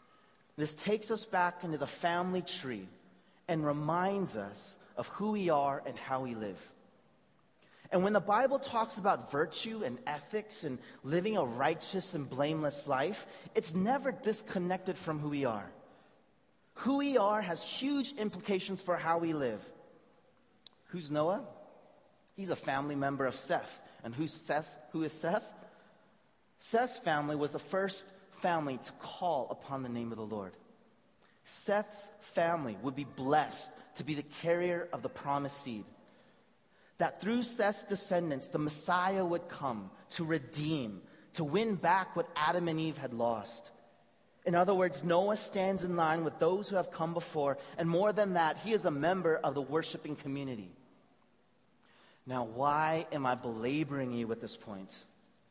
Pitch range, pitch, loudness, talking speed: 140-195 Hz, 165 Hz, -34 LUFS, 160 wpm